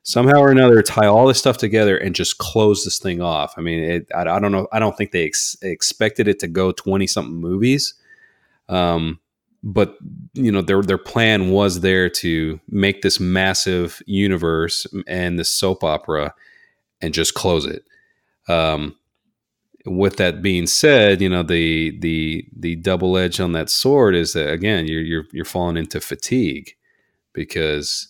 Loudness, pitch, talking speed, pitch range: -18 LUFS, 95 Hz, 170 wpm, 85-110 Hz